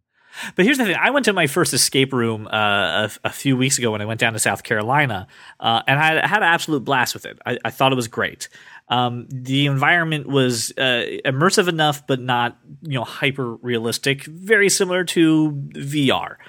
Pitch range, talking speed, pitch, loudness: 120-155 Hz, 205 wpm, 135 Hz, -19 LUFS